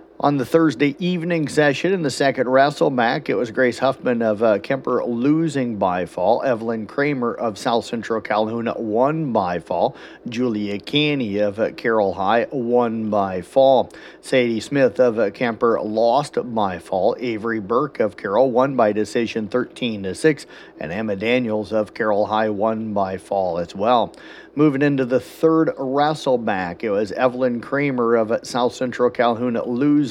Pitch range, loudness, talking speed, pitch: 110-140 Hz, -20 LUFS, 160 wpm, 125 Hz